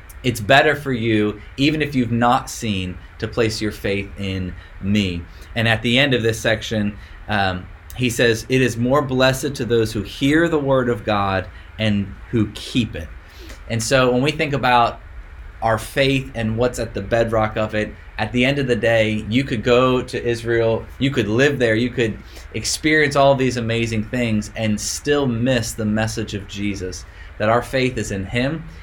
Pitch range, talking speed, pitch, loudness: 100-125 Hz, 190 wpm, 115 Hz, -19 LUFS